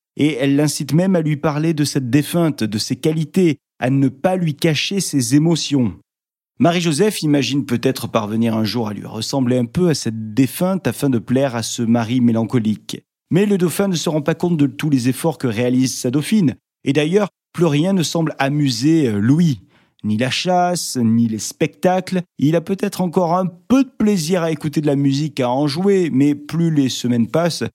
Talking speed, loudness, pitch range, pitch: 200 wpm, -18 LUFS, 125-170 Hz, 150 Hz